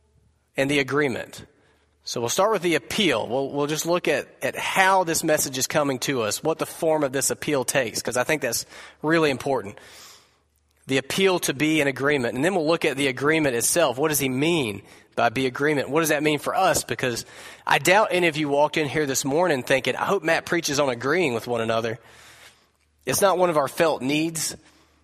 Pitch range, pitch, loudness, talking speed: 120-160 Hz, 145 Hz, -22 LUFS, 215 wpm